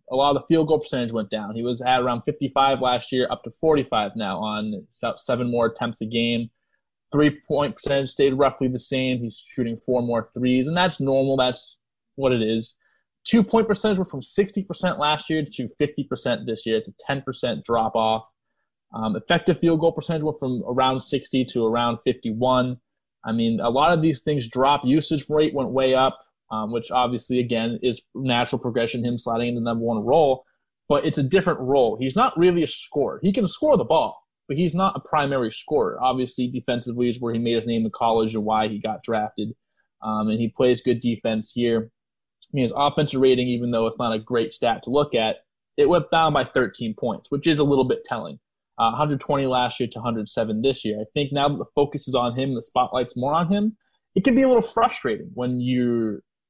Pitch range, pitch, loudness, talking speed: 115-145 Hz, 125 Hz, -23 LUFS, 215 wpm